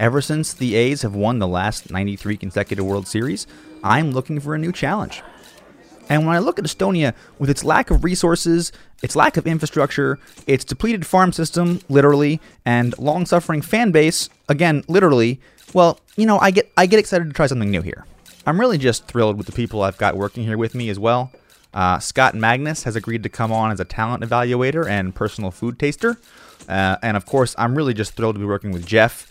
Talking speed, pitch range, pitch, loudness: 205 wpm, 110-155 Hz, 125 Hz, -19 LUFS